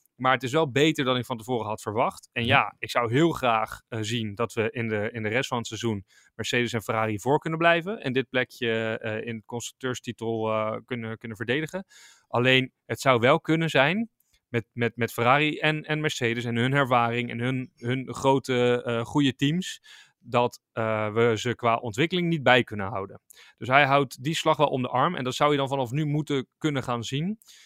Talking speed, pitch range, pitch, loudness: 215 wpm, 115-145 Hz, 125 Hz, -25 LUFS